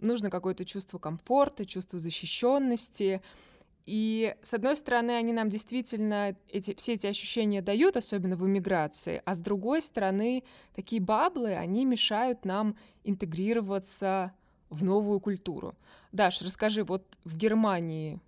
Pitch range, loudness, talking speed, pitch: 190-230 Hz, -30 LUFS, 130 wpm, 205 Hz